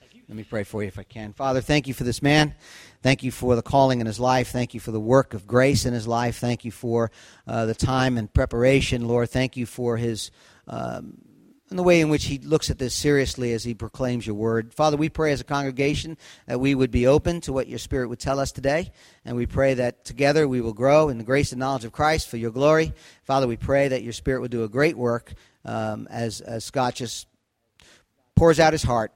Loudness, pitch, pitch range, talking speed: -23 LUFS, 125 Hz, 115-140 Hz, 245 wpm